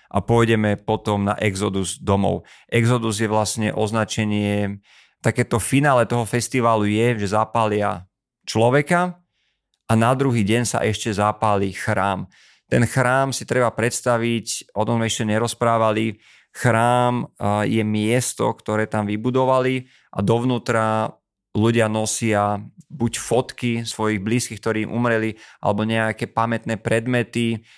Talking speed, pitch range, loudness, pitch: 120 wpm, 105-120 Hz, -21 LUFS, 115 Hz